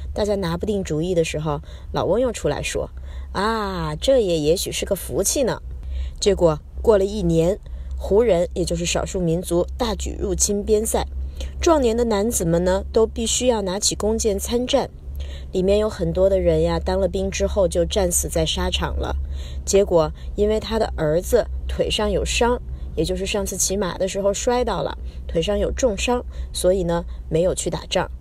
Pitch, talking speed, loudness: 175 Hz, 260 characters per minute, -21 LUFS